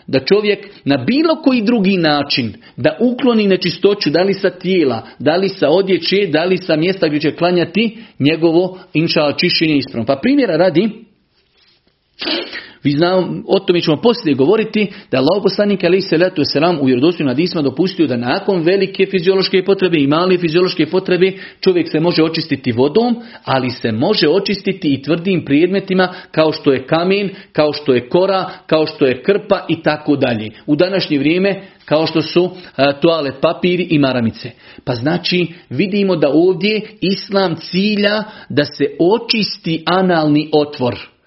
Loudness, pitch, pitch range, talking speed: -15 LUFS, 175 Hz, 150-195 Hz, 155 wpm